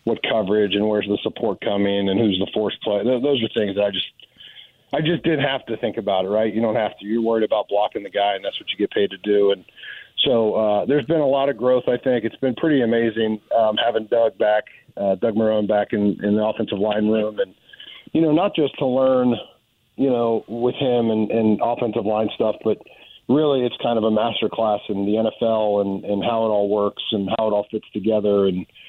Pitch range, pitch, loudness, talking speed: 105-125 Hz, 110 Hz, -21 LUFS, 235 wpm